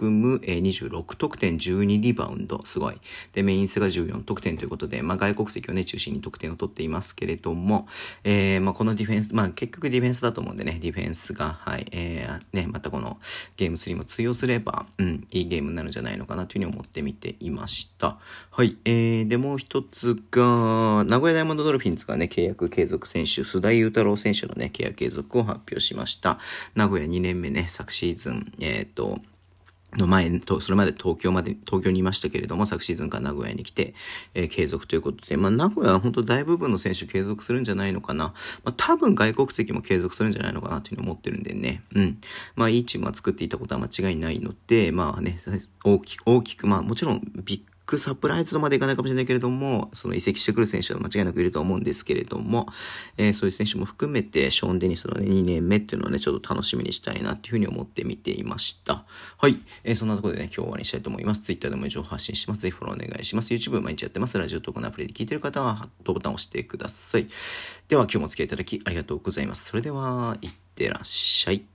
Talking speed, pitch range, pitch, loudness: 490 characters per minute, 95-120 Hz, 105 Hz, -25 LUFS